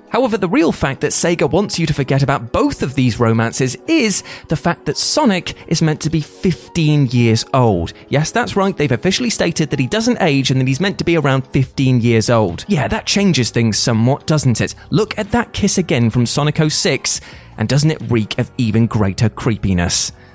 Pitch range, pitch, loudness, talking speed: 120-170 Hz, 140 Hz, -15 LUFS, 205 wpm